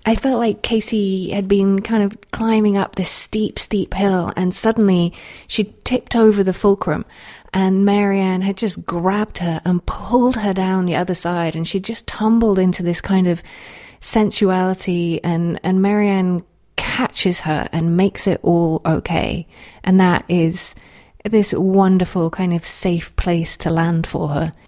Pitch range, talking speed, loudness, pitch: 175-205 Hz, 160 wpm, -18 LUFS, 190 Hz